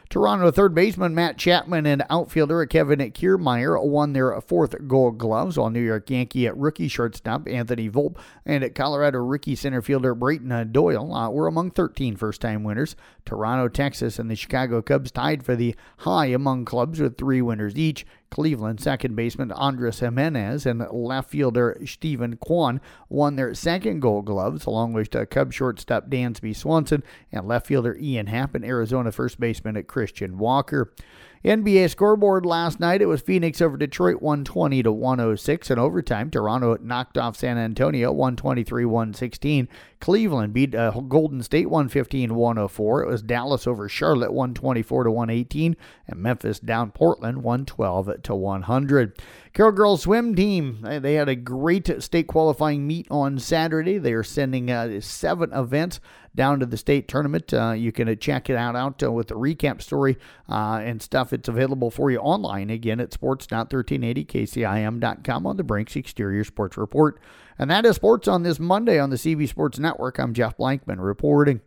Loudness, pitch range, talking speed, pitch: -23 LUFS, 115-150 Hz, 165 wpm, 130 Hz